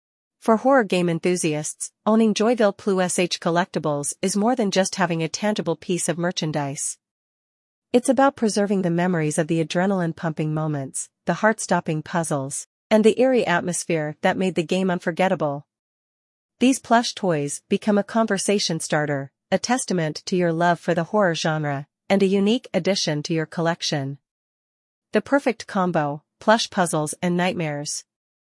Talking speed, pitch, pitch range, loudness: 150 wpm, 175 Hz, 155-200 Hz, -22 LUFS